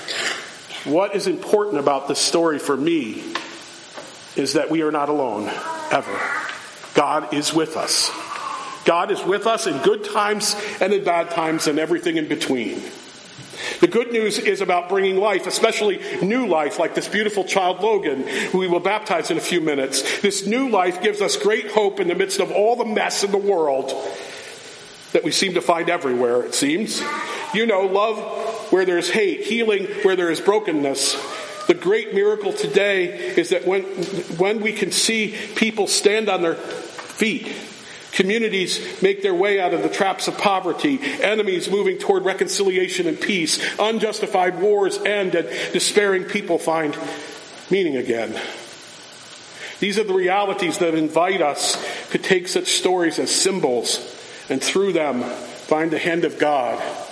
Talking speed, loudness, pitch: 165 wpm, -20 LUFS, 210 Hz